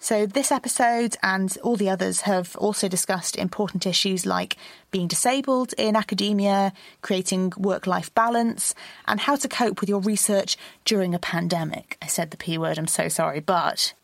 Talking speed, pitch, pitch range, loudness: 170 wpm, 200 Hz, 185-225 Hz, -23 LUFS